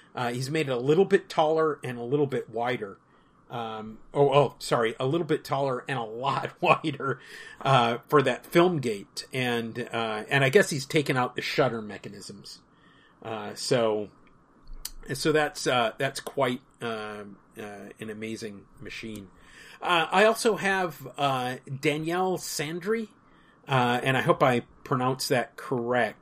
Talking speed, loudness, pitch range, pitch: 155 wpm, -27 LUFS, 120-155 Hz, 135 Hz